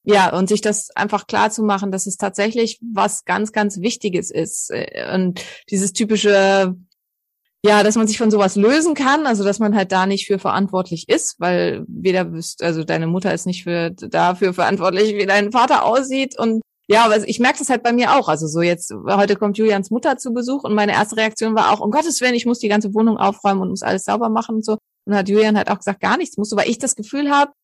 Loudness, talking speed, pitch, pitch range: -17 LUFS, 225 wpm, 210 Hz, 195-225 Hz